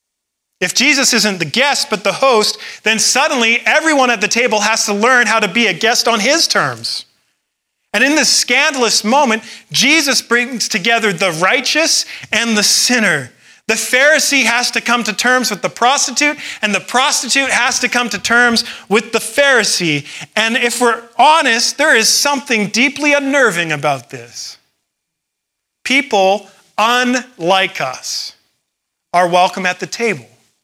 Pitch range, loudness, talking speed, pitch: 205-260 Hz, -12 LUFS, 155 wpm, 230 Hz